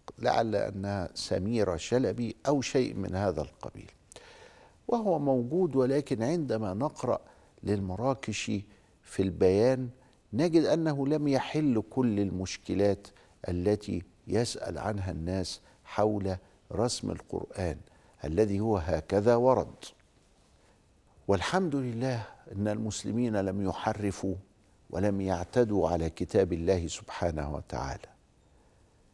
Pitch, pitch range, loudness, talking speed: 105 Hz, 95-125 Hz, -30 LUFS, 95 wpm